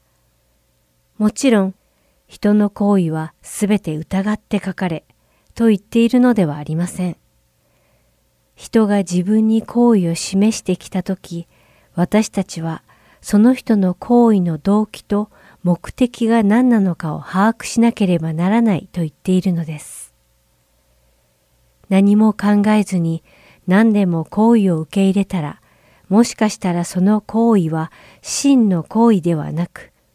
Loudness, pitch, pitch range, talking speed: -17 LUFS, 190 Hz, 160-215 Hz, 250 characters per minute